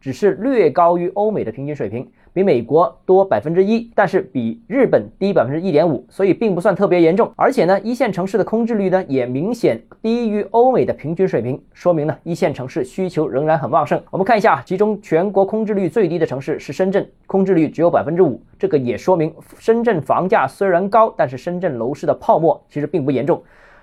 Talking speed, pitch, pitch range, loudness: 340 characters per minute, 185 Hz, 160-215 Hz, -17 LUFS